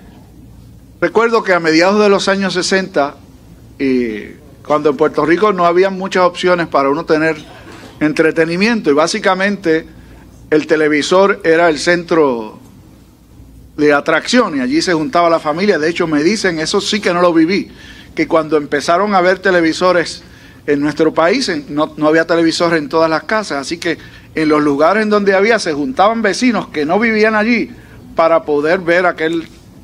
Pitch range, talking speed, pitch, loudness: 150-190 Hz, 165 wpm, 165 Hz, -13 LUFS